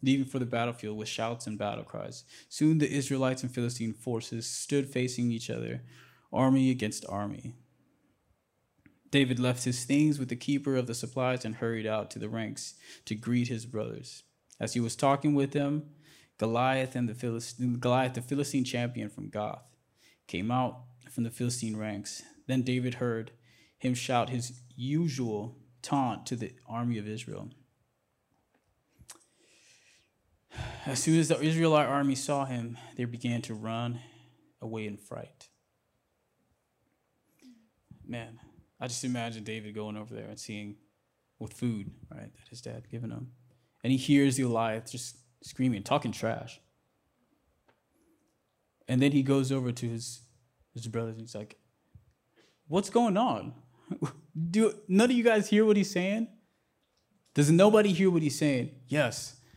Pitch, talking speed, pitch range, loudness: 125 Hz, 150 wpm, 115-140 Hz, -30 LUFS